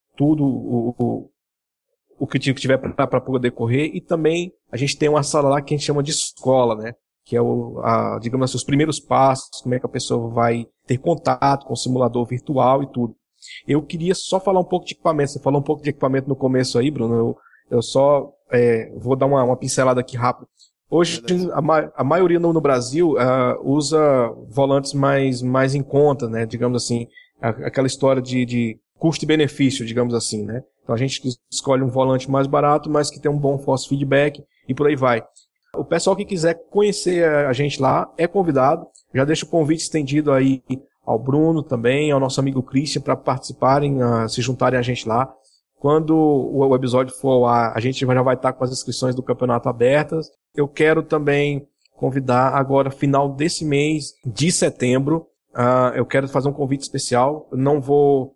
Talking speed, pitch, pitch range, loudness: 195 wpm, 135 Hz, 125-150 Hz, -19 LUFS